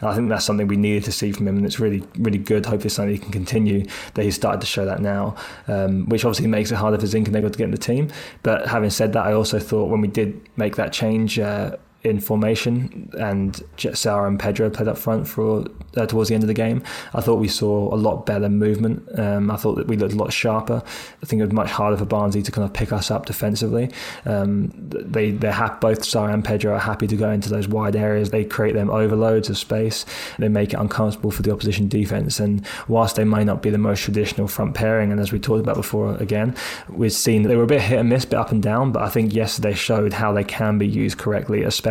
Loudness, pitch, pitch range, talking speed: -21 LUFS, 105 Hz, 105-110 Hz, 255 wpm